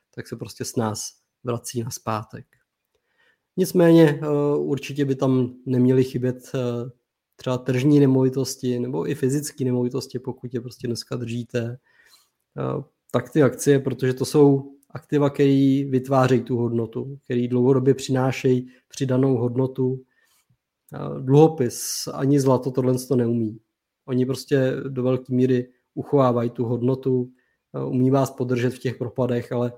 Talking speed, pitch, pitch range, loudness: 125 wpm, 130 Hz, 125-135 Hz, -22 LUFS